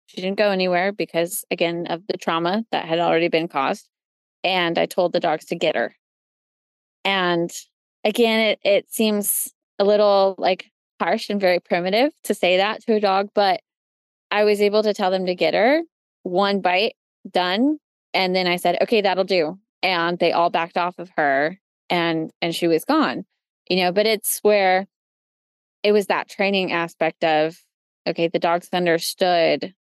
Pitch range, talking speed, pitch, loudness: 170-210 Hz, 175 wpm, 185 Hz, -21 LUFS